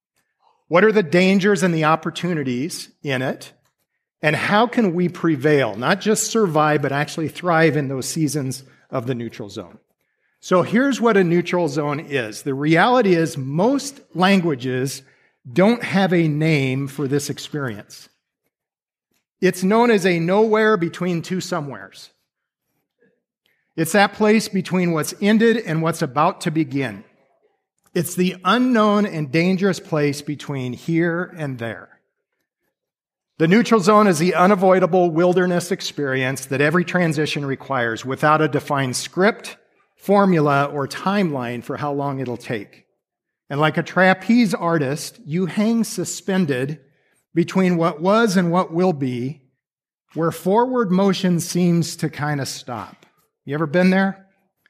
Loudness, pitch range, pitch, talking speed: -19 LUFS, 145-190 Hz, 170 Hz, 140 wpm